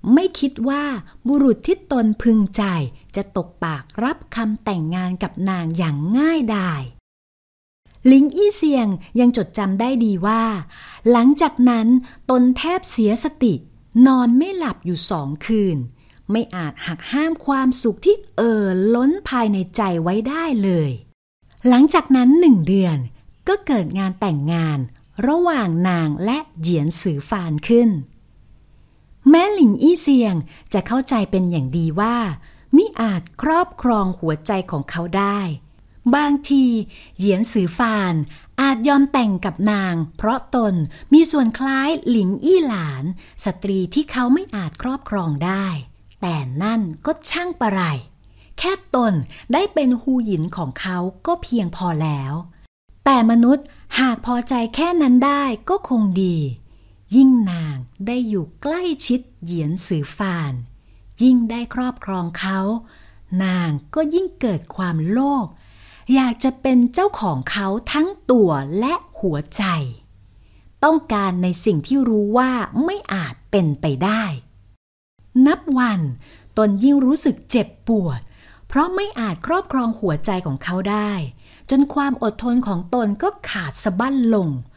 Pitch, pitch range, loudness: 215 Hz, 170-260 Hz, -18 LUFS